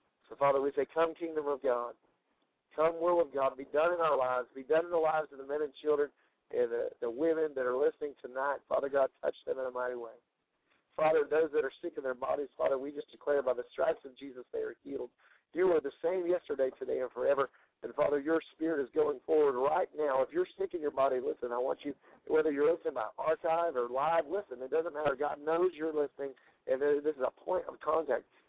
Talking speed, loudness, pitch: 235 wpm, -33 LUFS, 160 Hz